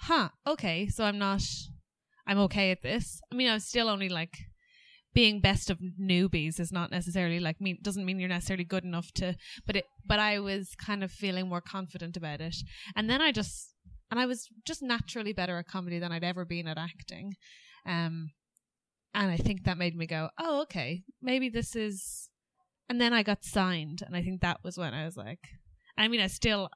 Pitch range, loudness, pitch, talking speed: 175-215 Hz, -31 LUFS, 190 Hz, 210 wpm